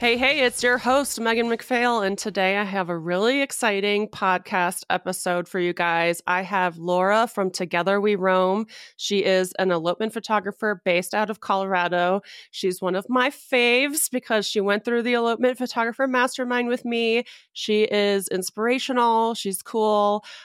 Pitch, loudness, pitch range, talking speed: 210 Hz, -22 LUFS, 185-240 Hz, 160 wpm